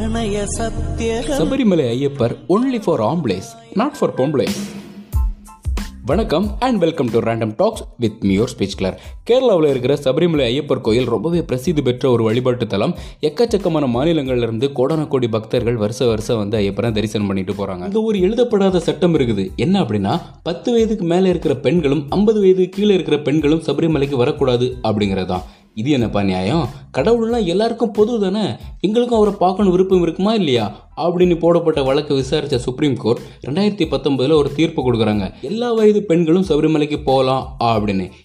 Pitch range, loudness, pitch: 115-185 Hz, -17 LUFS, 145 Hz